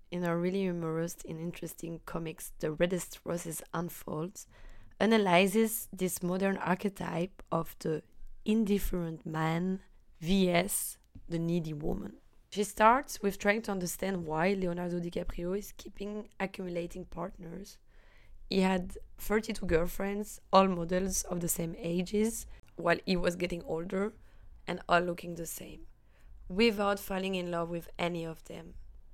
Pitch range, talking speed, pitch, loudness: 165-195 Hz, 130 wpm, 175 Hz, -33 LUFS